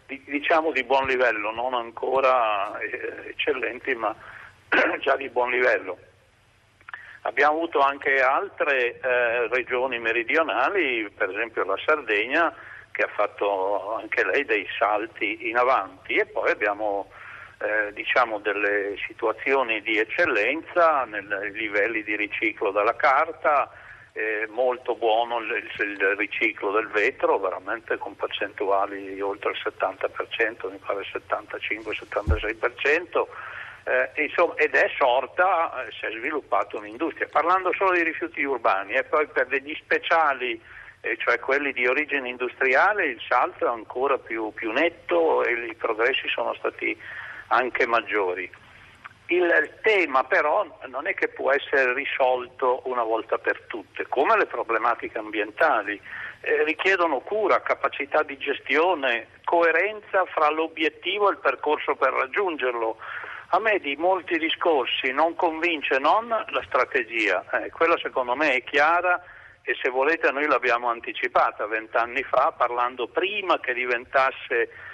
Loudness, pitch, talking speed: -24 LUFS, 180 Hz, 130 wpm